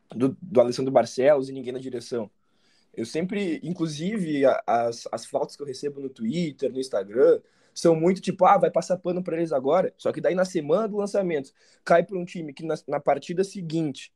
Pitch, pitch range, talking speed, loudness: 165 Hz, 135-185 Hz, 200 wpm, -25 LUFS